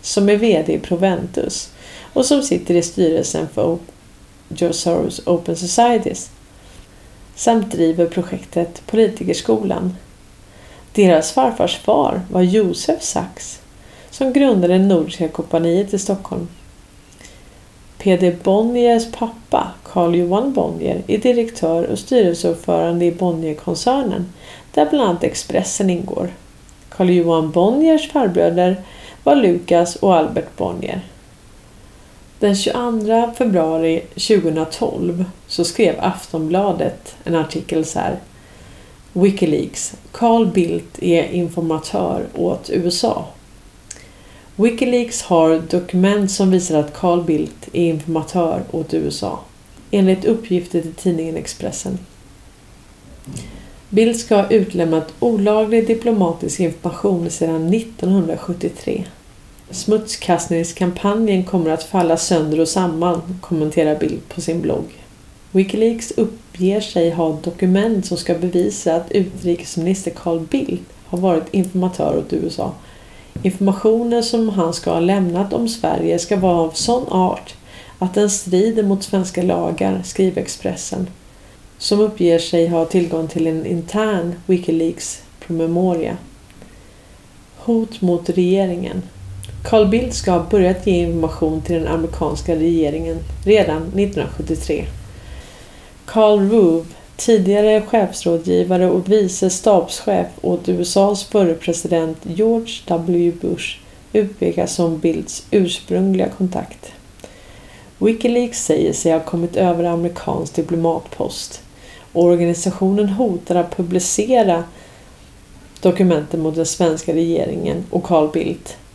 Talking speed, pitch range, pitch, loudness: 110 wpm, 165-205 Hz, 175 Hz, -17 LUFS